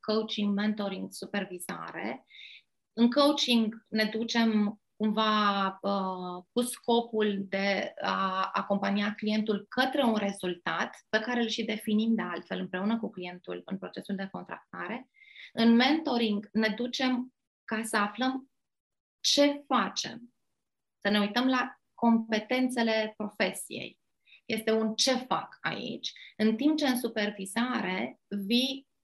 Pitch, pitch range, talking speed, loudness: 220 Hz, 200-245 Hz, 120 wpm, -29 LUFS